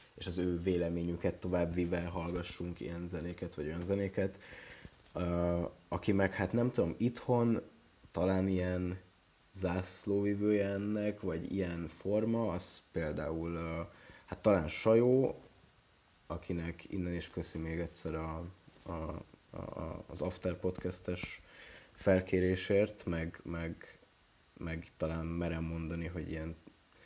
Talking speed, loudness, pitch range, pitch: 115 wpm, -36 LUFS, 85-95 Hz, 90 Hz